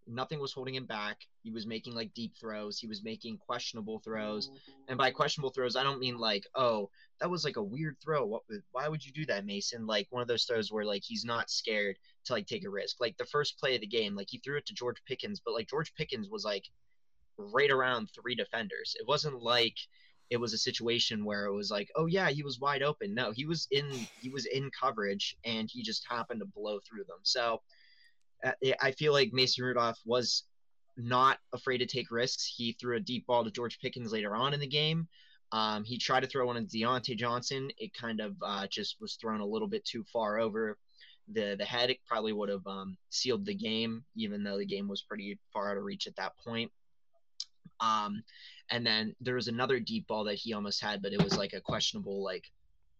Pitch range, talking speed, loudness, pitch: 110-140 Hz, 225 wpm, -34 LUFS, 120 Hz